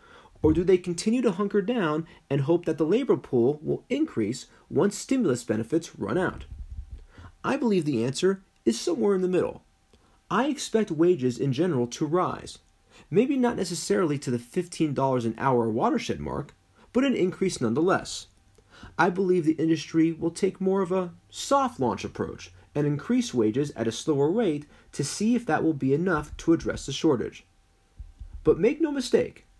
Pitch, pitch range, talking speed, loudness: 160 Hz, 115-190 Hz, 170 wpm, -26 LUFS